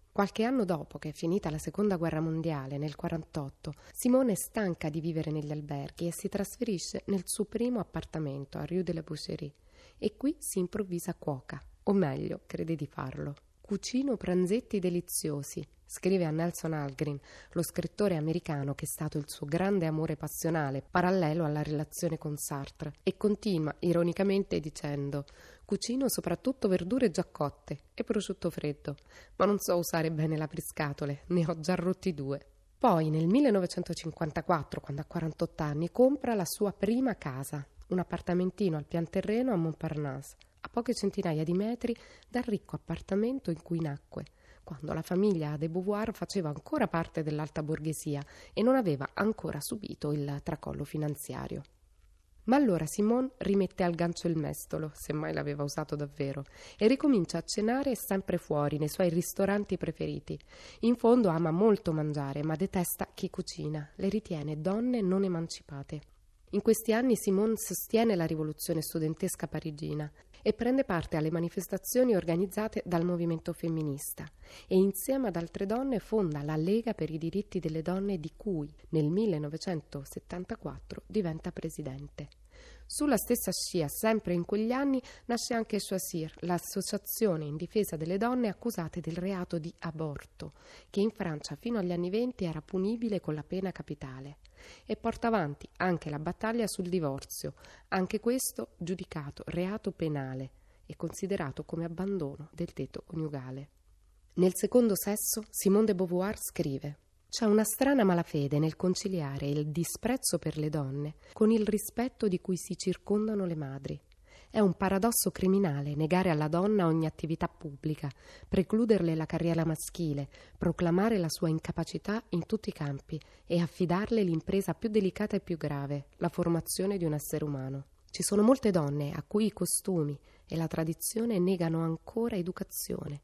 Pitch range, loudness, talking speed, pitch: 155-200 Hz, -32 LUFS, 155 wpm, 175 Hz